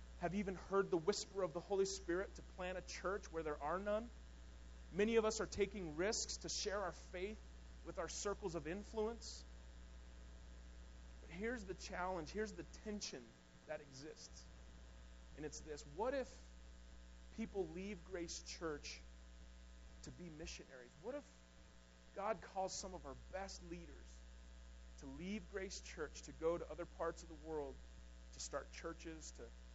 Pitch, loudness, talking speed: 155 Hz, -46 LUFS, 155 wpm